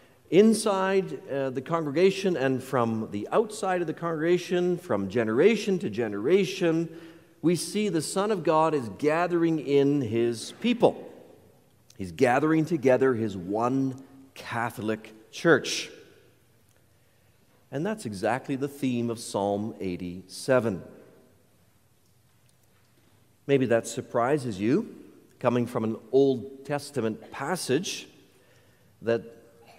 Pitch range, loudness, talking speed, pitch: 115-165 Hz, -26 LUFS, 105 wpm, 130 Hz